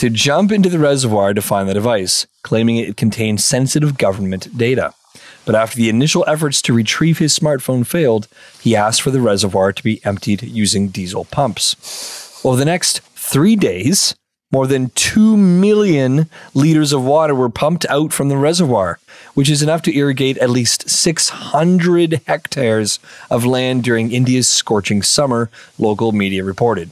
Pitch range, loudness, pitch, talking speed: 110-150 Hz, -15 LUFS, 130 Hz, 160 wpm